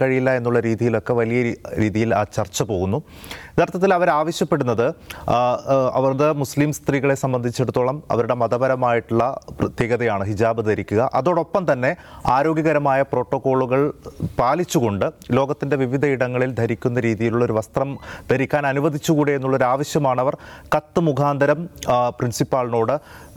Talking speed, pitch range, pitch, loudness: 95 wpm, 120-145 Hz, 130 Hz, -20 LUFS